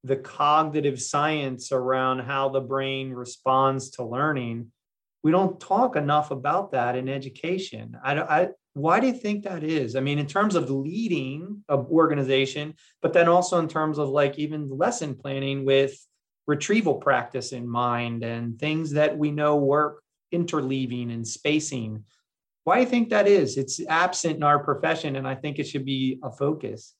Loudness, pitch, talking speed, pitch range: -25 LUFS, 145 Hz, 170 wpm, 135-155 Hz